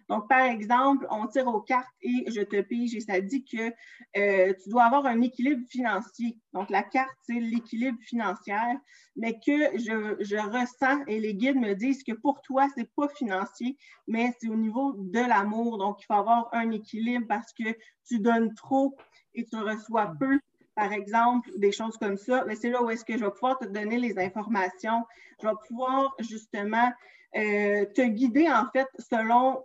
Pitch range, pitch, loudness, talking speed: 215-260 Hz, 235 Hz, -28 LUFS, 190 wpm